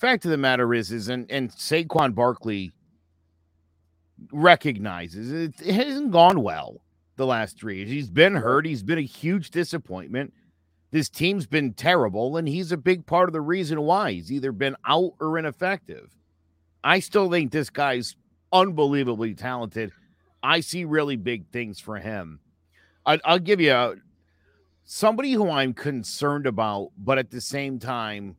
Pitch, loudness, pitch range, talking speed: 135 Hz, -23 LUFS, 100-165 Hz, 160 wpm